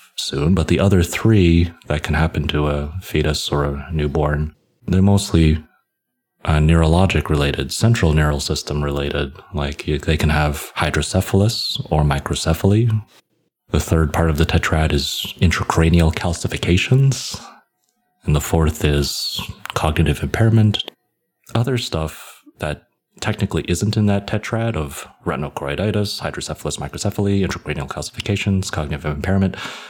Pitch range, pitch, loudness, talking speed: 75-100 Hz, 80 Hz, -19 LUFS, 120 wpm